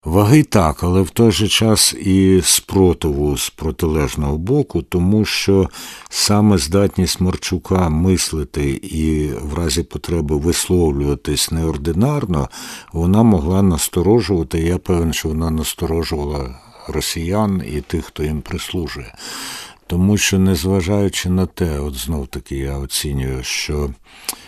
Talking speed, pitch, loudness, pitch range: 120 wpm, 85 Hz, -17 LUFS, 75-95 Hz